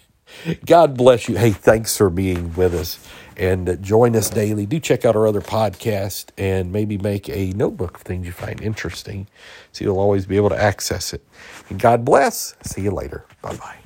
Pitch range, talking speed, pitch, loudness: 95-110 Hz, 195 wpm, 100 Hz, -19 LUFS